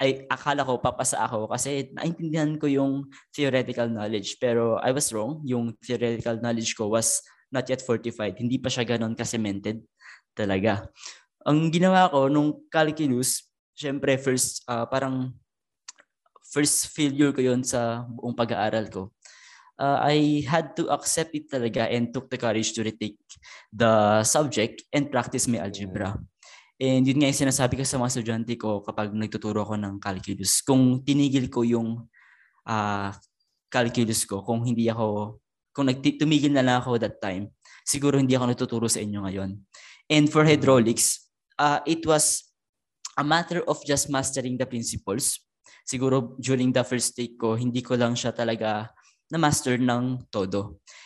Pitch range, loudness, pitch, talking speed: 110-135 Hz, -25 LUFS, 125 Hz, 155 wpm